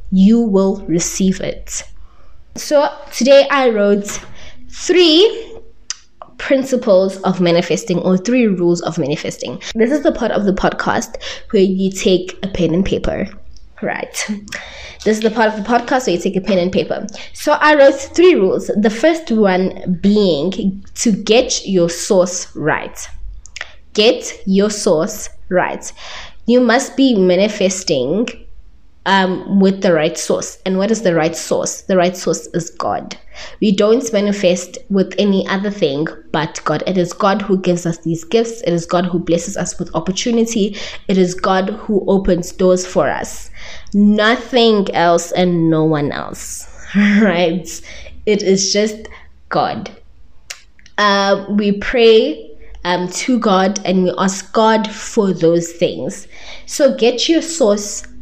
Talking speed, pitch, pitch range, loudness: 150 wpm, 195 Hz, 180-225 Hz, -15 LUFS